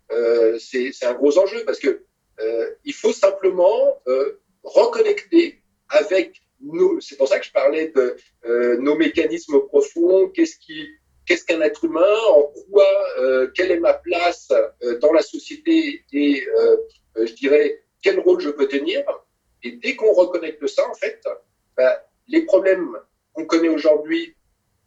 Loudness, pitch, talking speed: -19 LUFS, 295 Hz, 160 wpm